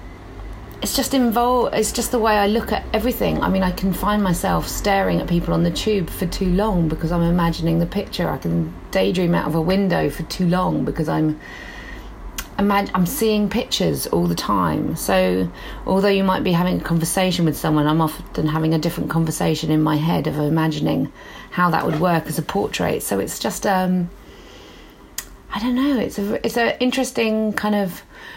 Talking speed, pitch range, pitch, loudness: 190 wpm, 160-205 Hz, 180 Hz, -20 LUFS